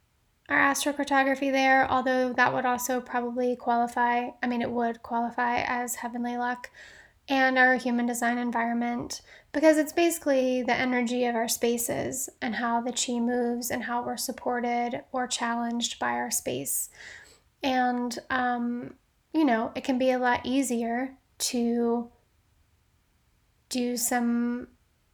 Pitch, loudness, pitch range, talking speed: 245 Hz, -27 LUFS, 235-255 Hz, 135 wpm